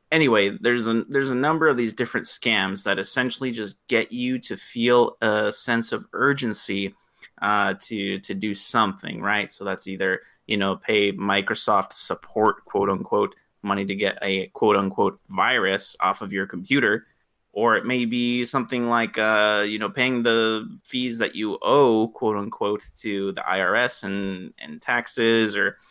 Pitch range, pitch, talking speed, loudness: 100-120 Hz, 110 Hz, 165 wpm, -23 LUFS